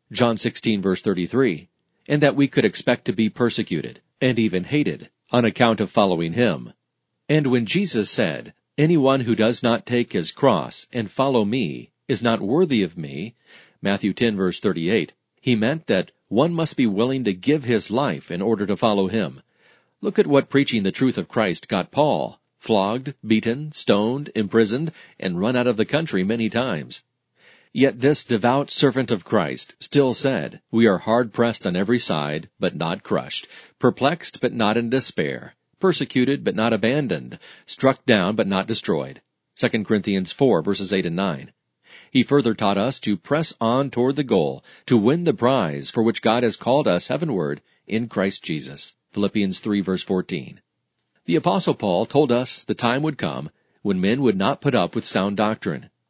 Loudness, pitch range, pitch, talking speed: -21 LUFS, 105-135 Hz, 120 Hz, 180 wpm